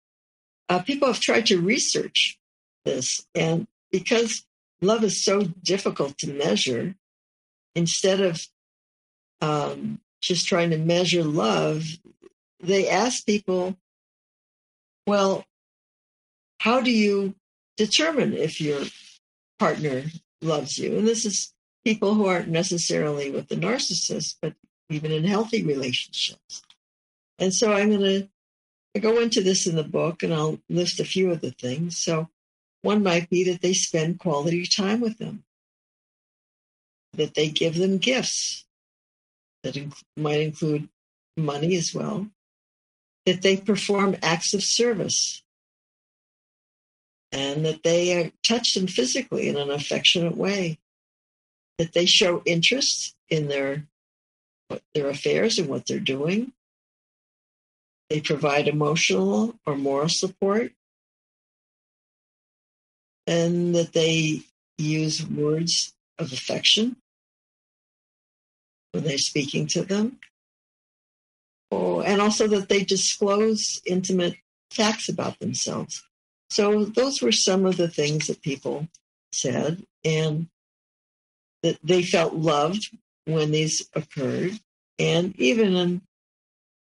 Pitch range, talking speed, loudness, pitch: 155-205 Hz, 115 wpm, -23 LUFS, 180 Hz